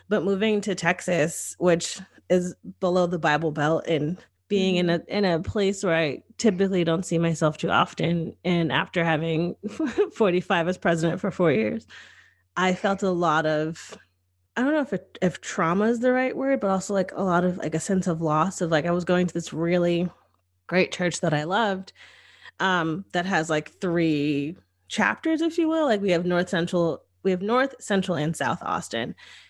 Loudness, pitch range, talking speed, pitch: -24 LUFS, 165-195 Hz, 195 wpm, 175 Hz